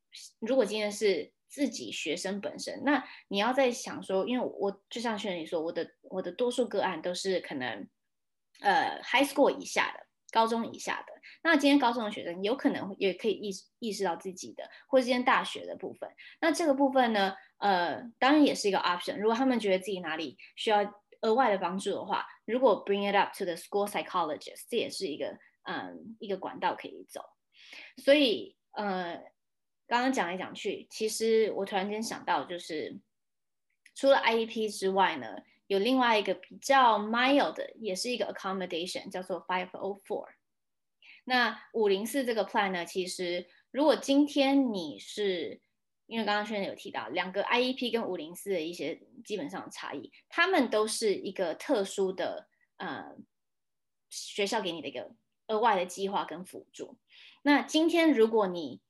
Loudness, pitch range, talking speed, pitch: -30 LUFS, 190-260 Hz, 325 characters per minute, 215 Hz